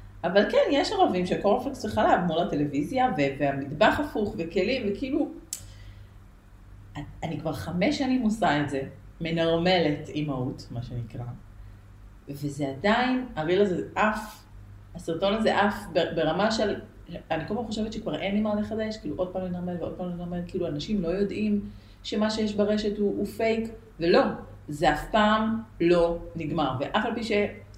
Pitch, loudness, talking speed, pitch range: 175 Hz, -27 LUFS, 150 wpm, 140-215 Hz